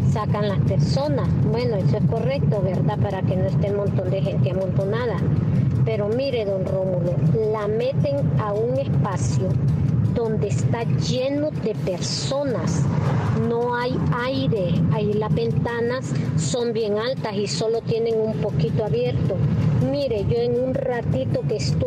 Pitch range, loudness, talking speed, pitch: 140-175 Hz, -22 LUFS, 145 wpm, 150 Hz